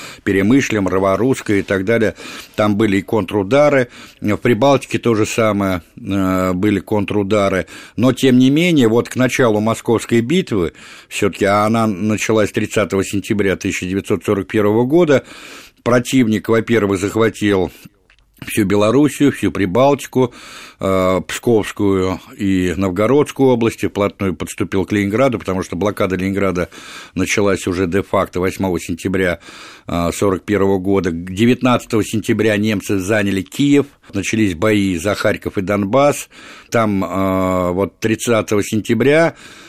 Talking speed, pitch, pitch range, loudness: 115 wpm, 105 Hz, 95-115 Hz, -16 LUFS